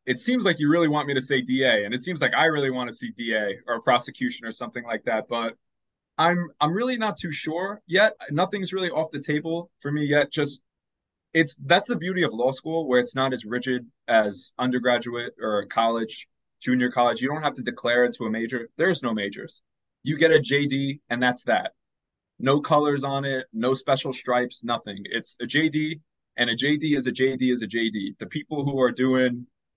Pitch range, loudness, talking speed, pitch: 120-155 Hz, -24 LUFS, 210 wpm, 135 Hz